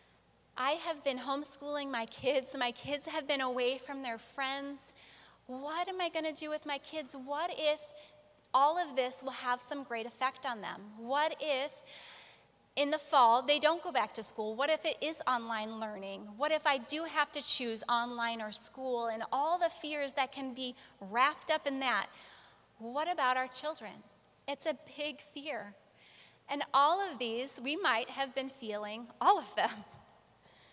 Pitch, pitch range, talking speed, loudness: 275 Hz, 245-300 Hz, 180 wpm, -34 LUFS